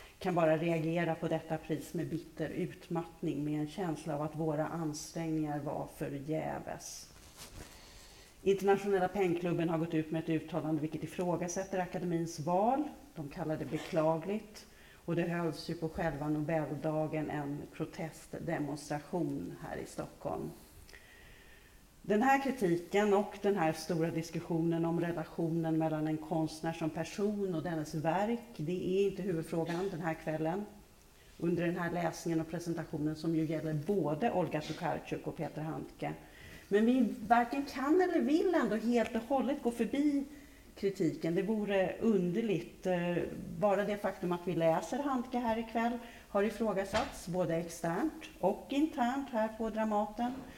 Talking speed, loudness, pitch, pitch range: 145 wpm, -35 LUFS, 170 Hz, 160-205 Hz